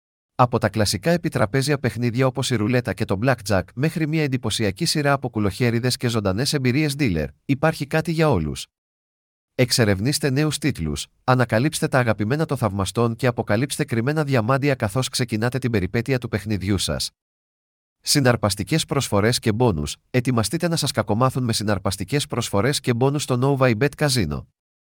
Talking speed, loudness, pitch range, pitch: 150 wpm, -21 LUFS, 105-140 Hz, 125 Hz